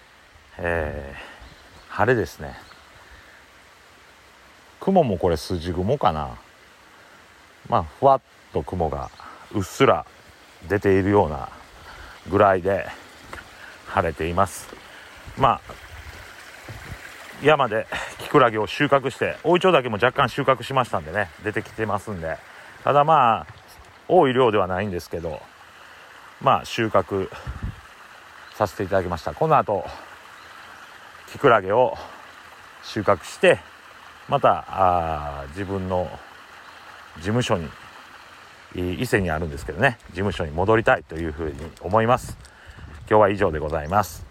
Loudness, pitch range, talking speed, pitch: -22 LUFS, 85-110 Hz, 235 characters per minute, 100 Hz